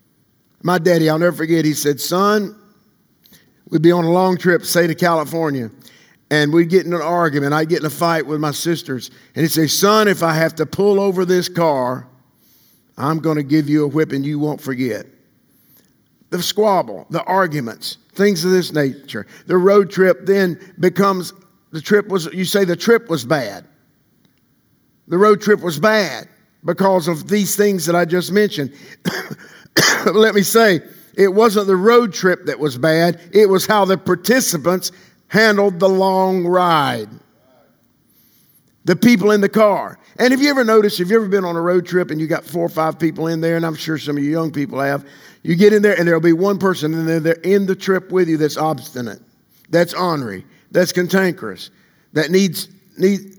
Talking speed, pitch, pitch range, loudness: 195 wpm, 175 Hz, 160-195 Hz, -16 LUFS